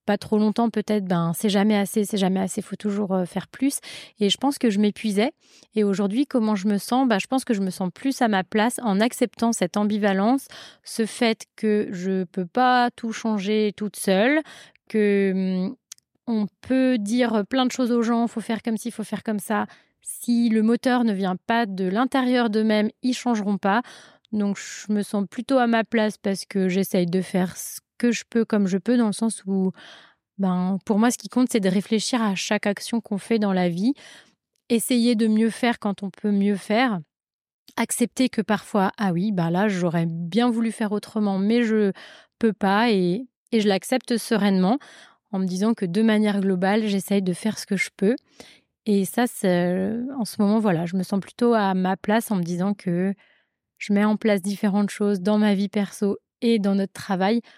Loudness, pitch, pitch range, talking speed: -23 LUFS, 210 Hz, 195-235 Hz, 210 wpm